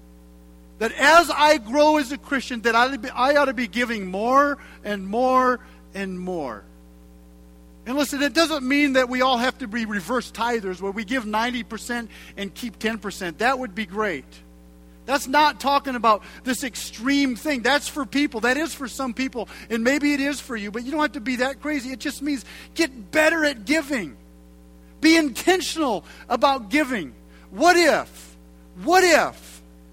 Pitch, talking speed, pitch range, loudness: 250 Hz, 175 wpm, 200-285 Hz, -22 LUFS